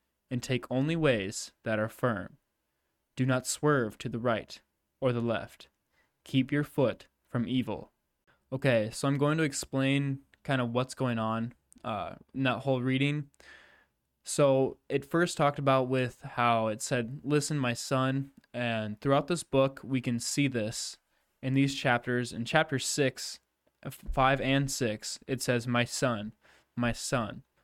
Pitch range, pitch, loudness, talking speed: 115-135 Hz, 130 Hz, -30 LUFS, 155 wpm